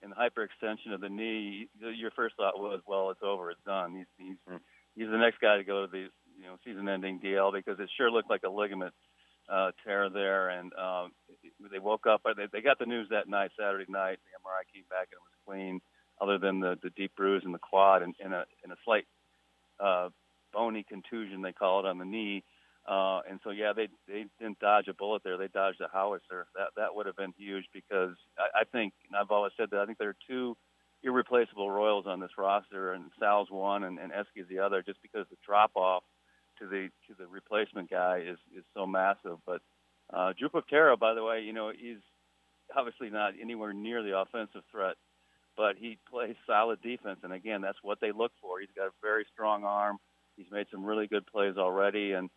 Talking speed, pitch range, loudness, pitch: 215 wpm, 95-105 Hz, -32 LUFS, 100 Hz